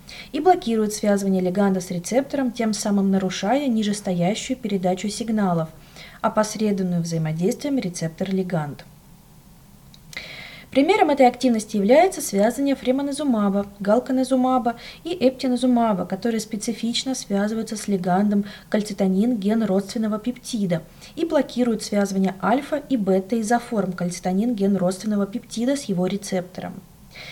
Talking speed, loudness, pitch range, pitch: 105 wpm, -22 LUFS, 190-245 Hz, 215 Hz